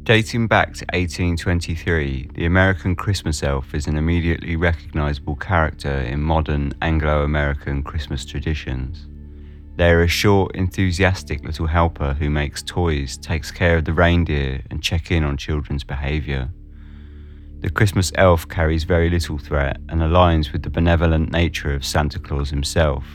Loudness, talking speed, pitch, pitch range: -20 LUFS, 145 wpm, 80 Hz, 75-85 Hz